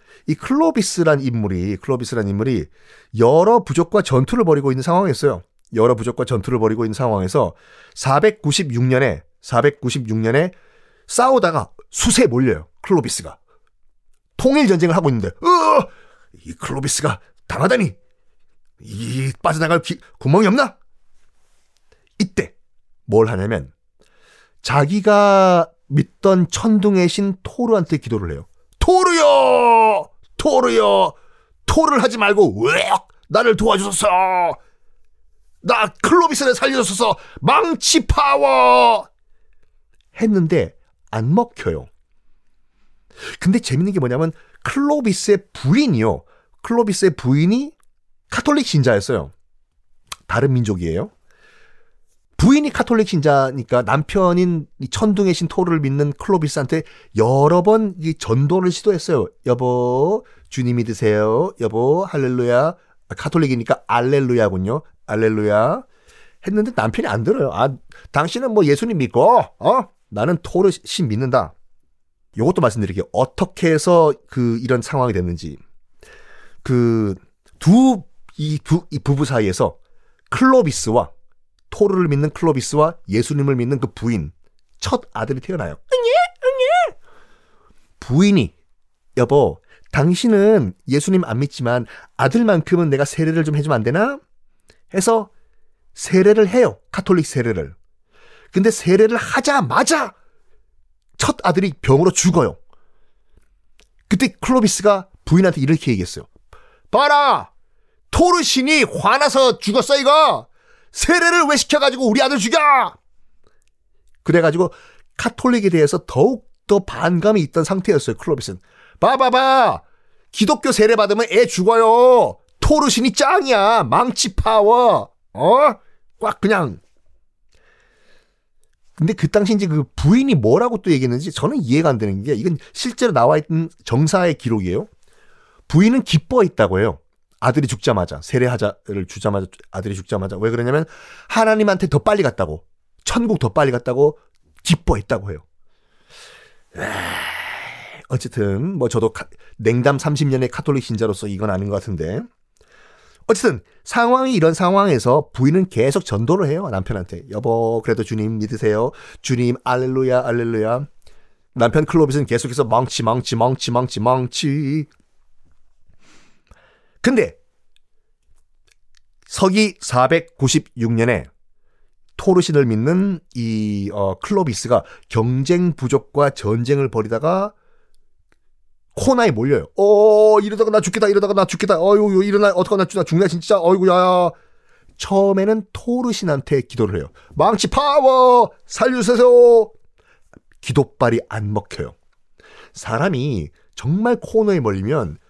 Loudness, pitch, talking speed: -17 LUFS, 160 Hz, 270 characters per minute